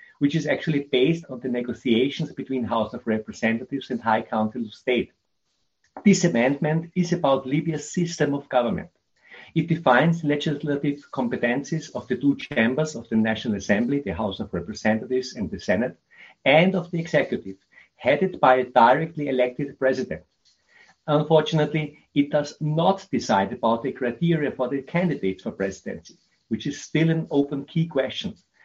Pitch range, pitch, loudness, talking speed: 120-155 Hz, 140 Hz, -24 LUFS, 155 wpm